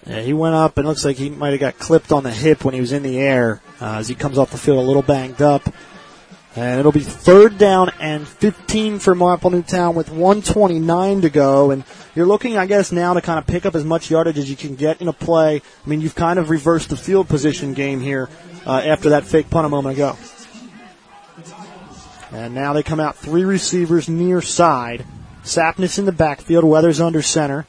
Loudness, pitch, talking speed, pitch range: -16 LUFS, 160 Hz, 225 wpm, 140-175 Hz